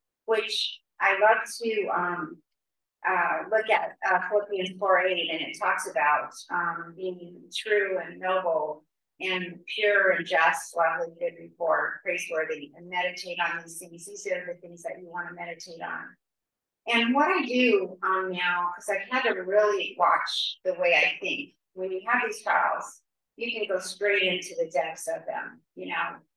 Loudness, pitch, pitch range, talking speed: -27 LUFS, 185 Hz, 175-210 Hz, 175 wpm